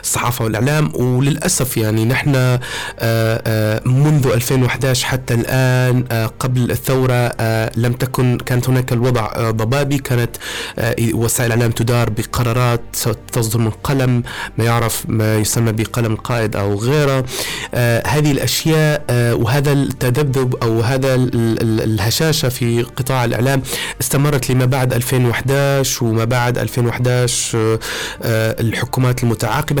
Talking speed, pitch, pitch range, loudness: 105 wpm, 120 Hz, 115-130 Hz, -16 LUFS